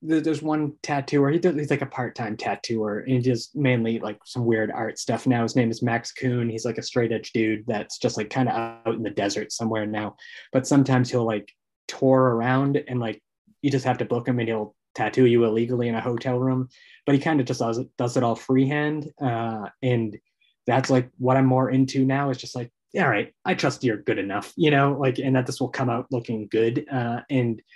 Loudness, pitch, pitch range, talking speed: -24 LUFS, 125 Hz, 115-135 Hz, 225 wpm